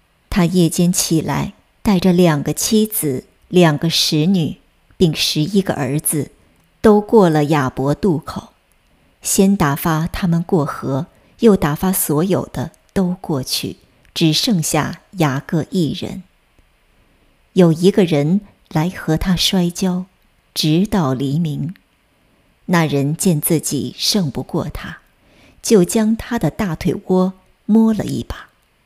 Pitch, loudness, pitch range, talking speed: 170 Hz, -17 LUFS, 150-195 Hz, 175 characters per minute